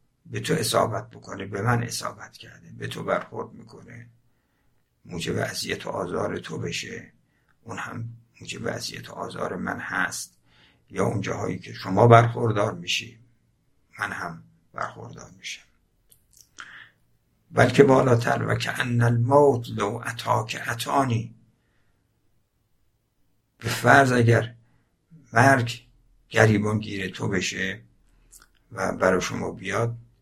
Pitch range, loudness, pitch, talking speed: 105-120 Hz, -24 LUFS, 115 Hz, 115 wpm